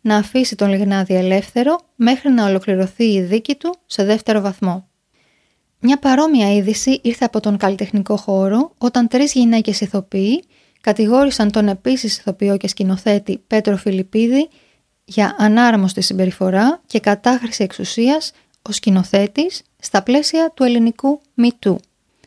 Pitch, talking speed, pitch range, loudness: 215 Hz, 125 wpm, 200-255 Hz, -16 LUFS